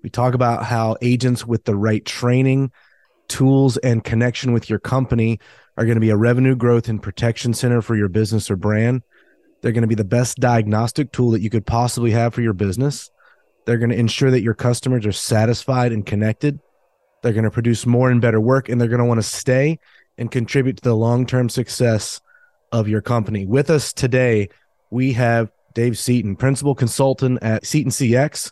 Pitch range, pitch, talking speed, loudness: 115-130 Hz, 120 Hz, 195 wpm, -18 LUFS